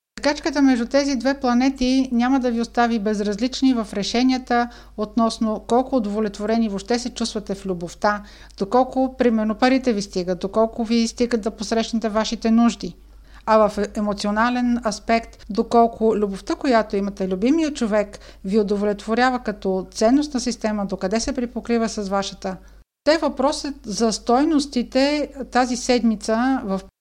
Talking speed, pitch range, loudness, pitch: 130 wpm, 210-250 Hz, -21 LUFS, 230 Hz